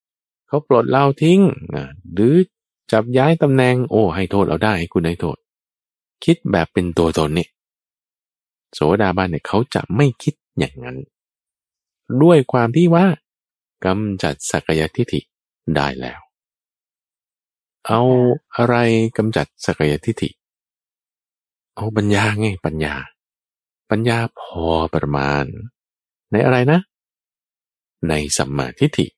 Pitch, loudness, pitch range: 105 Hz, -18 LUFS, 80-125 Hz